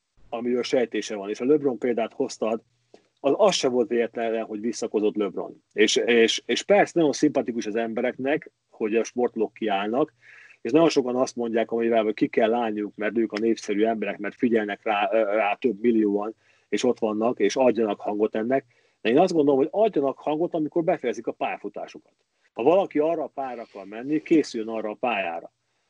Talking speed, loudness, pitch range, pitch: 175 wpm, -24 LUFS, 110-135 Hz, 120 Hz